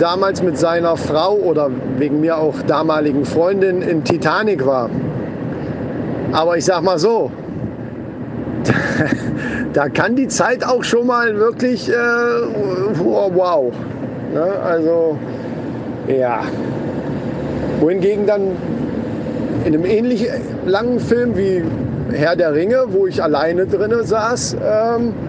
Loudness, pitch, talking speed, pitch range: -17 LUFS, 190 Hz, 110 wpm, 160-235 Hz